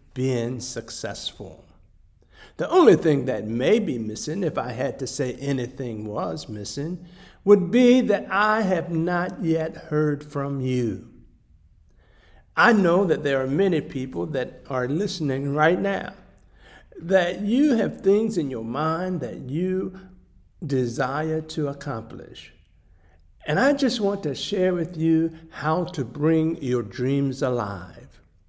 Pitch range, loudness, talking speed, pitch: 120-175 Hz, -23 LUFS, 135 wpm, 145 Hz